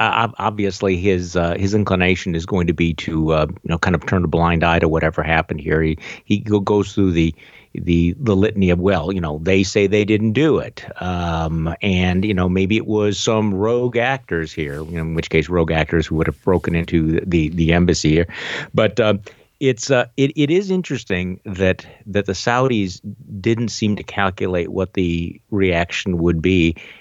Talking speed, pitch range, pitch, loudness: 200 wpm, 85-105 Hz, 90 Hz, -18 LUFS